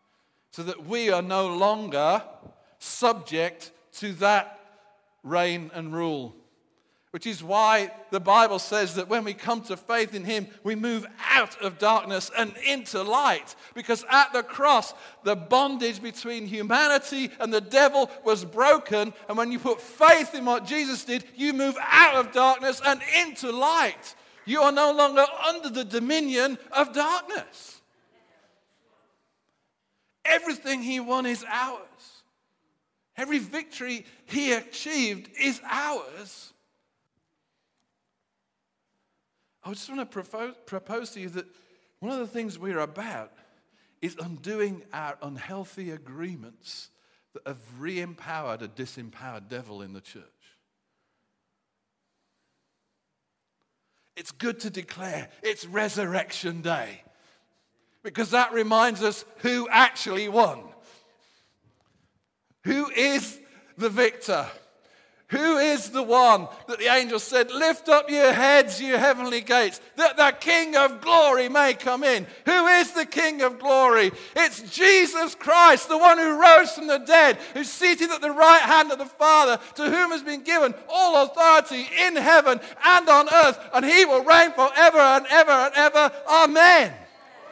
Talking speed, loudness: 140 wpm, -20 LUFS